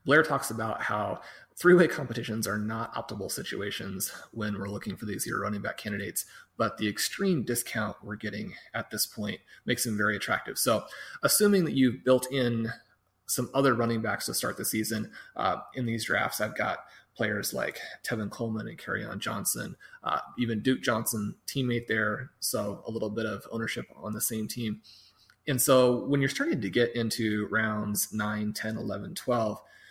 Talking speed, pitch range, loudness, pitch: 180 wpm, 105-125 Hz, -29 LUFS, 115 Hz